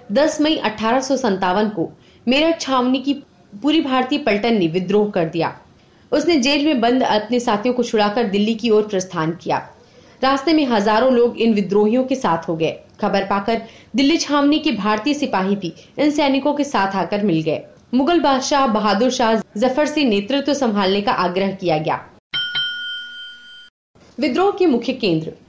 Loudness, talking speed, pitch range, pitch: -18 LUFS, 160 wpm, 205-285 Hz, 240 Hz